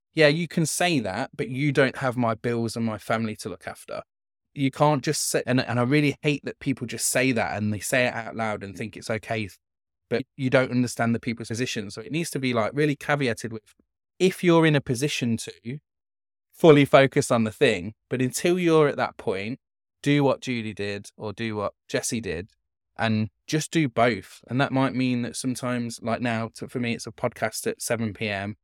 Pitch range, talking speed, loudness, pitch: 115-145 Hz, 220 wpm, -25 LUFS, 125 Hz